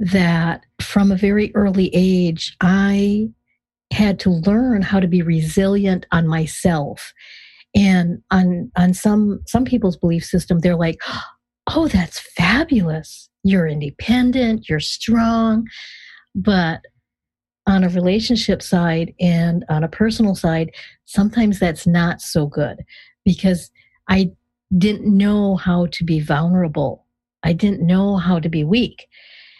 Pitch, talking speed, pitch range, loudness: 185 Hz, 130 wpm, 170-205 Hz, -18 LUFS